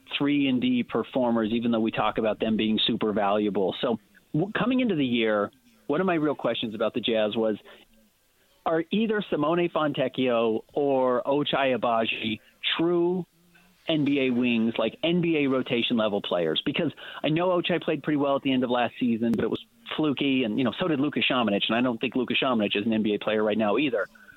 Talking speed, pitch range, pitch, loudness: 195 wpm, 115-170 Hz, 130 Hz, -26 LUFS